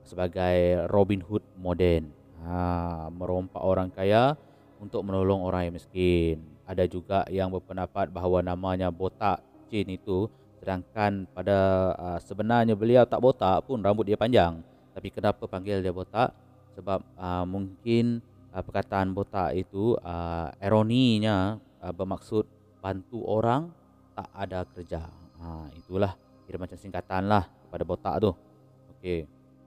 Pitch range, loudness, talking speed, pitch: 90-105 Hz, -28 LUFS, 130 wpm, 95 Hz